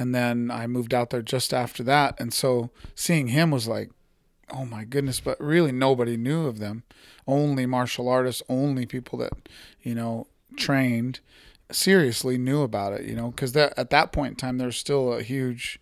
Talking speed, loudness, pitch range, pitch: 190 wpm, -25 LUFS, 120-135 Hz, 125 Hz